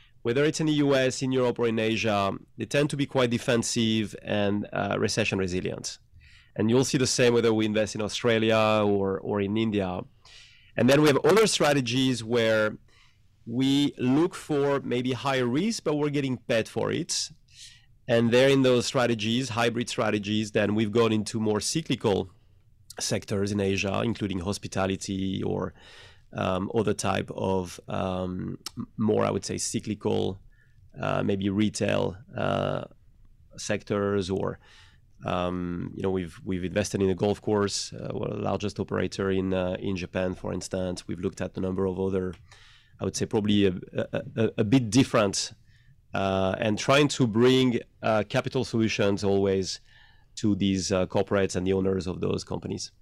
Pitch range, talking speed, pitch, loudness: 100-120 Hz, 165 wpm, 110 Hz, -26 LUFS